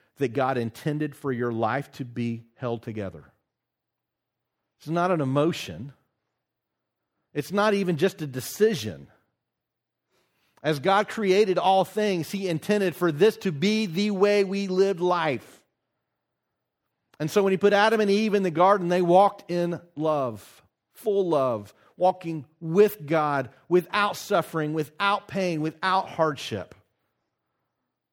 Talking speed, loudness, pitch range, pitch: 130 wpm, -25 LUFS, 140-195 Hz, 175 Hz